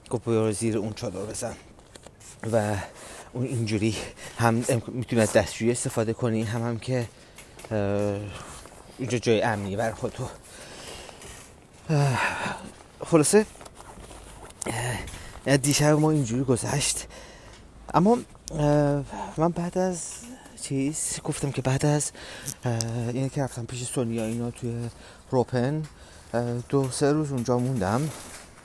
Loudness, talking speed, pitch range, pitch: -26 LUFS, 105 wpm, 115-140 Hz, 125 Hz